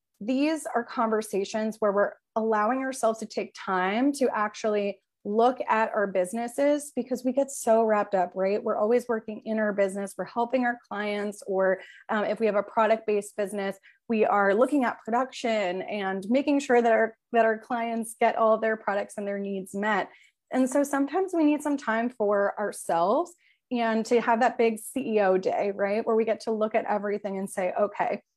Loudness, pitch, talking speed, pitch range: -26 LUFS, 220 Hz, 190 wpm, 205-240 Hz